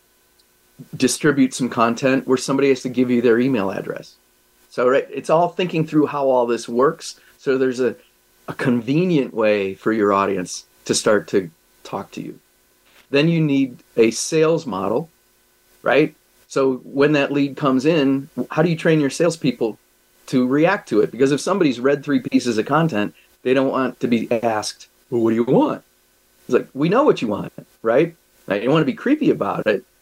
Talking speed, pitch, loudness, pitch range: 190 wpm, 130 Hz, -19 LUFS, 105-145 Hz